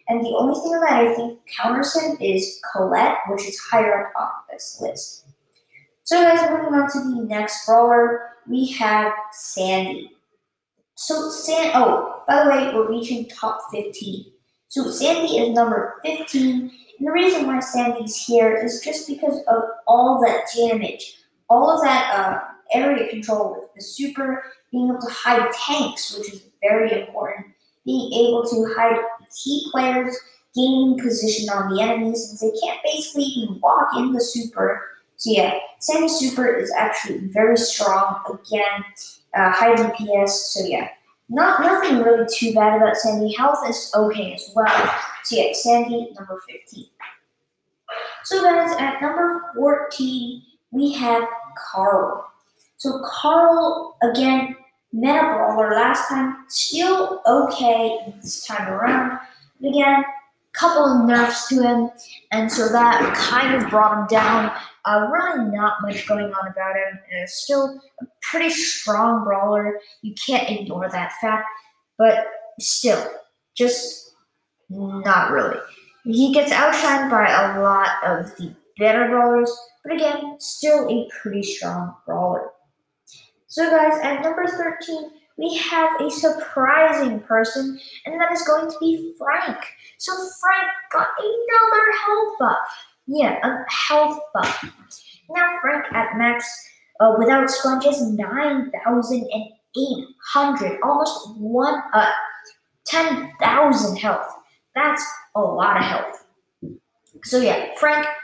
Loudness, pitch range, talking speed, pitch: -19 LUFS, 215-295 Hz, 140 wpm, 240 Hz